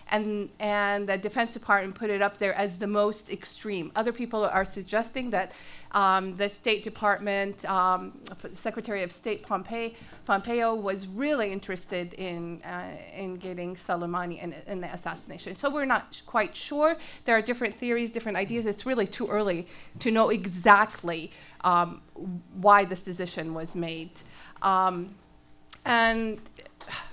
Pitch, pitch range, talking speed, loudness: 200 Hz, 185-220 Hz, 145 wpm, -28 LUFS